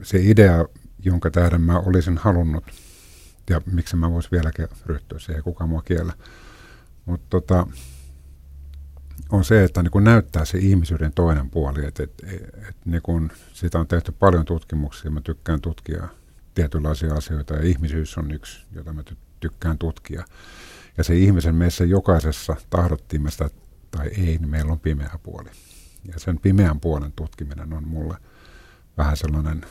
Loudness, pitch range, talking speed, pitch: -21 LUFS, 75-90 Hz, 145 wpm, 80 Hz